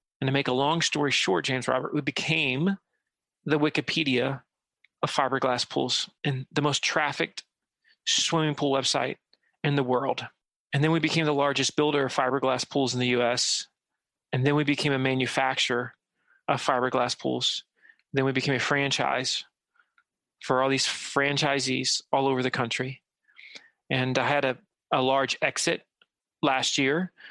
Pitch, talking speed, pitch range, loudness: 135 Hz, 155 wpm, 130-150 Hz, -26 LUFS